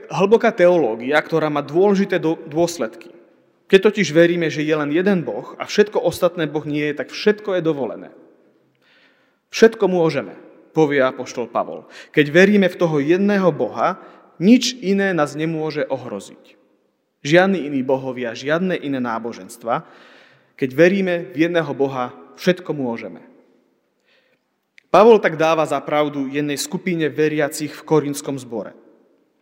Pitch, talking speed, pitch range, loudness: 160 Hz, 130 wpm, 145-180 Hz, -18 LUFS